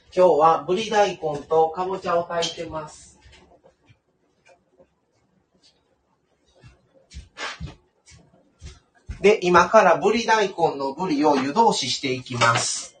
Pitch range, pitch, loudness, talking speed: 150-185 Hz, 170 Hz, -20 LUFS, 180 characters per minute